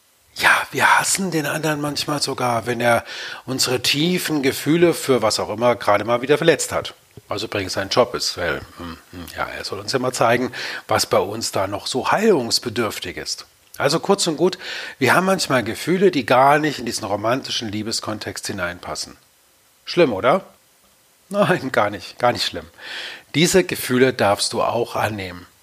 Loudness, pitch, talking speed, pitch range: -20 LUFS, 125 Hz, 170 wpm, 105-155 Hz